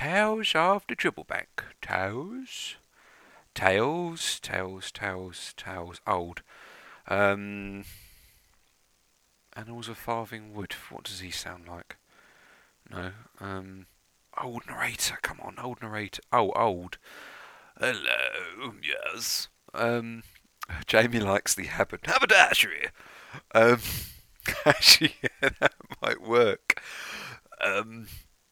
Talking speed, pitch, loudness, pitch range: 95 wpm, 100 Hz, -26 LUFS, 95-115 Hz